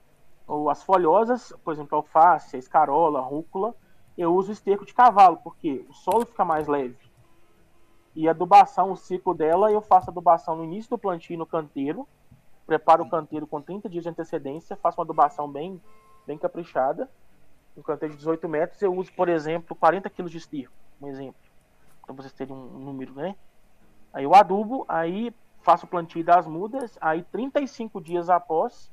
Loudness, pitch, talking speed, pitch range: -23 LUFS, 170 Hz, 175 wpm, 155-195 Hz